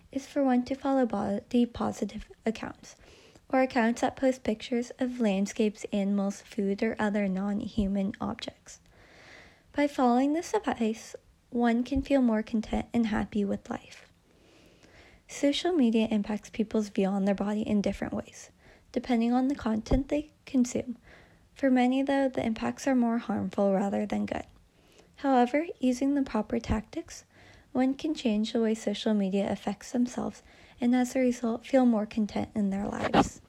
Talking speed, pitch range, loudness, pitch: 155 wpm, 210-260 Hz, -29 LUFS, 235 Hz